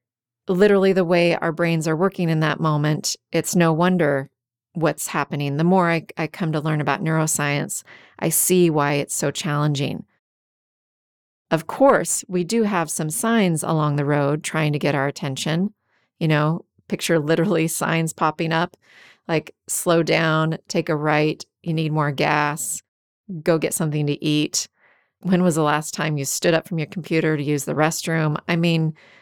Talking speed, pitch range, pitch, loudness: 175 wpm, 150-170 Hz, 160 Hz, -21 LUFS